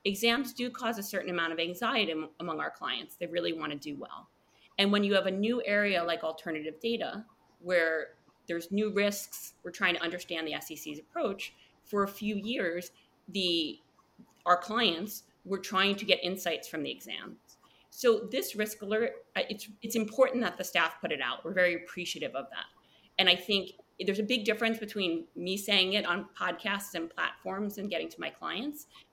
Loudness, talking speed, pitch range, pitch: -31 LUFS, 185 wpm, 175-215 Hz, 195 Hz